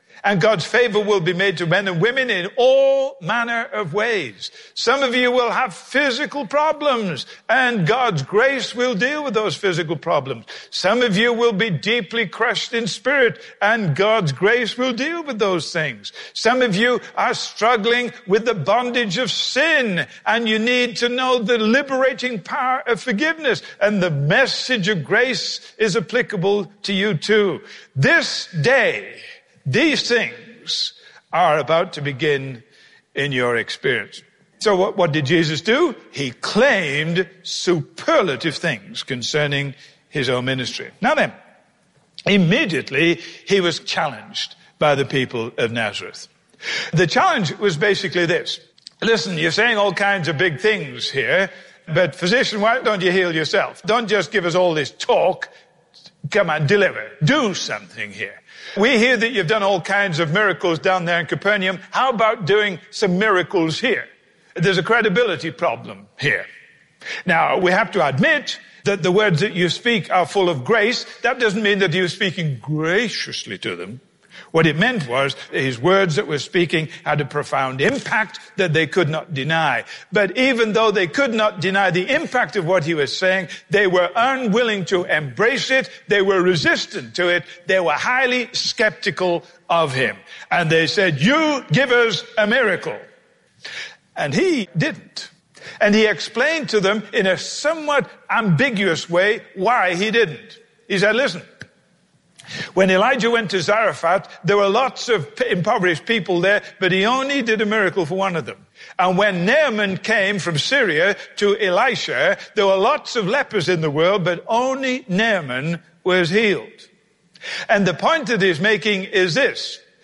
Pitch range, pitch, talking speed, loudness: 175-235 Hz, 200 Hz, 160 wpm, -18 LUFS